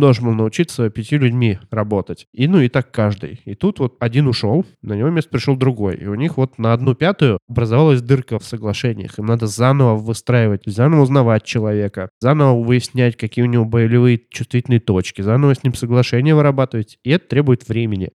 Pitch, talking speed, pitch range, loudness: 120 Hz, 185 wpm, 110-135 Hz, -16 LUFS